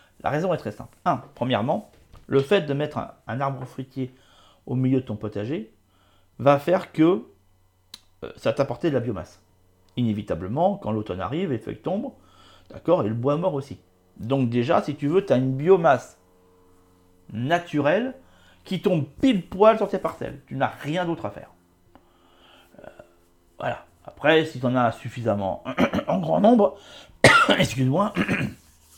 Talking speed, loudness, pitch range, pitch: 160 wpm, -23 LUFS, 95-145 Hz, 120 Hz